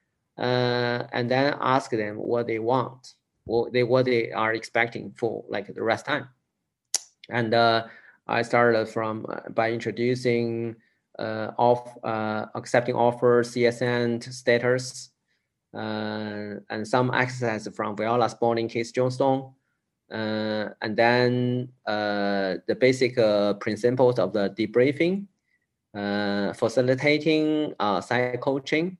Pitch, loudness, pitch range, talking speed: 120 Hz, -25 LUFS, 110-125 Hz, 120 wpm